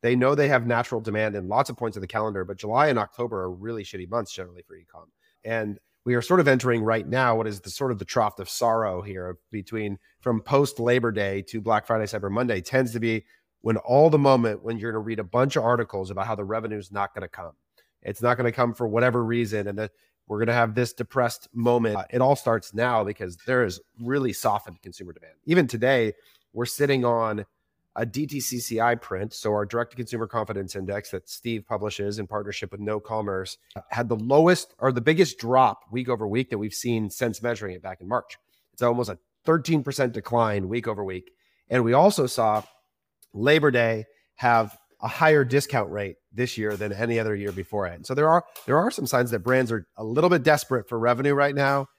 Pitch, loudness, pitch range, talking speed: 115 Hz, -25 LUFS, 105-125 Hz, 225 wpm